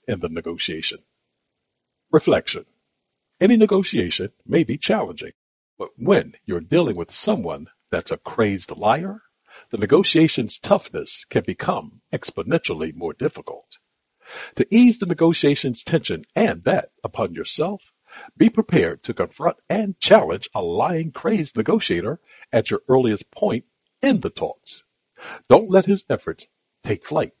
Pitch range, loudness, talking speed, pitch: 140-215 Hz, -21 LUFS, 130 wpm, 180 Hz